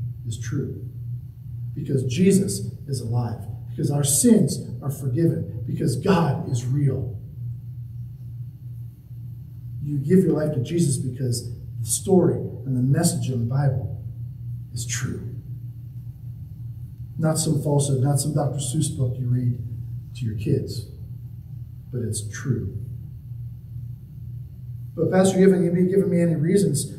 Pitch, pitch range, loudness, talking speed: 125 Hz, 120-140 Hz, -23 LUFS, 130 wpm